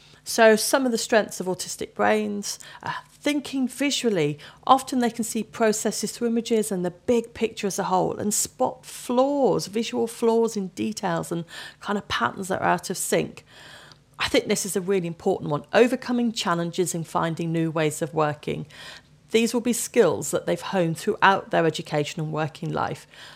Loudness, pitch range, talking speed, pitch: -24 LUFS, 170-235 Hz, 180 wpm, 205 Hz